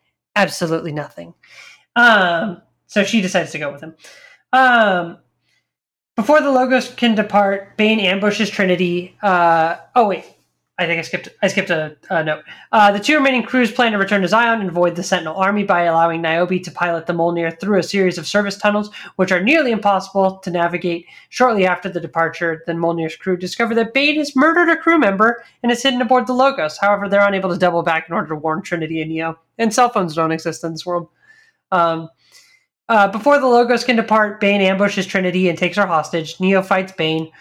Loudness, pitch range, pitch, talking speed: -16 LUFS, 170-225 Hz, 190 Hz, 200 wpm